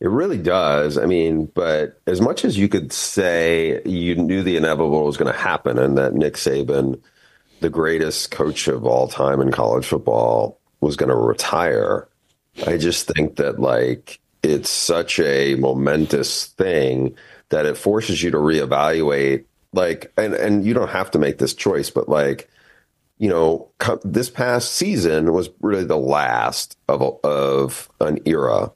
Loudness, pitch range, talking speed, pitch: -19 LUFS, 70-85 Hz, 165 wpm, 80 Hz